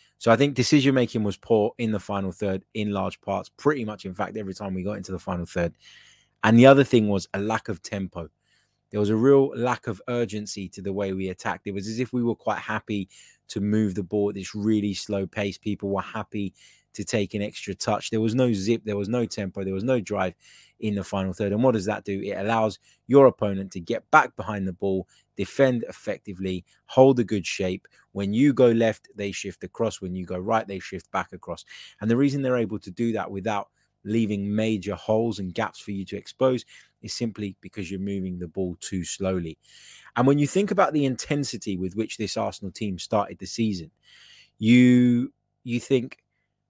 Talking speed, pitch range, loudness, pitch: 215 wpm, 95-115 Hz, -25 LUFS, 105 Hz